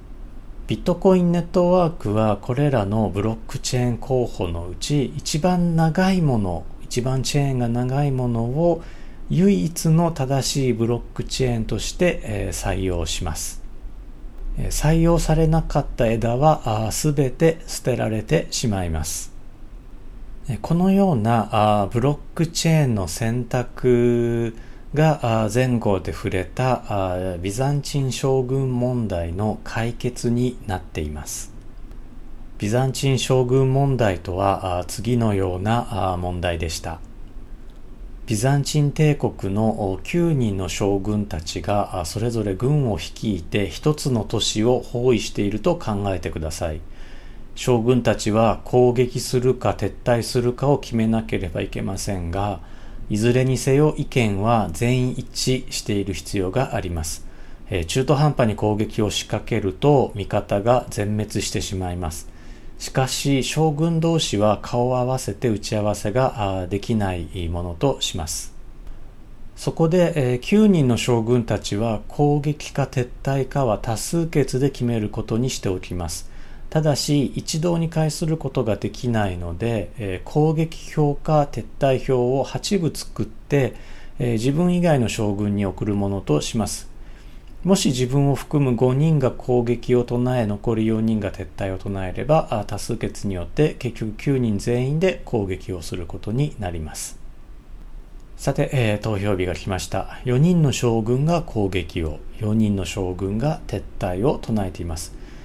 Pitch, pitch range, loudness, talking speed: 120 Hz, 100-135 Hz, -22 LUFS, 275 characters per minute